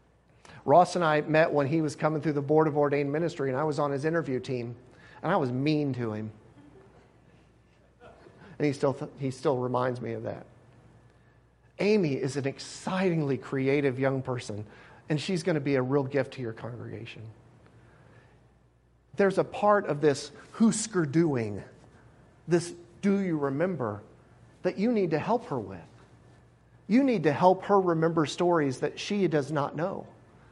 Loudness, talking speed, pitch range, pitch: -28 LUFS, 165 wpm, 125-165 Hz, 145 Hz